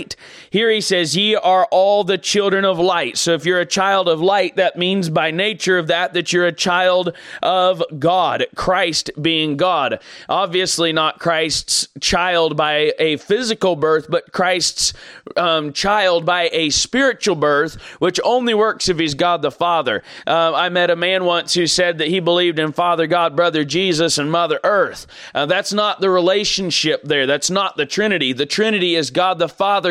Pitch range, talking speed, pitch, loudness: 165-190 Hz, 185 wpm, 175 Hz, -16 LUFS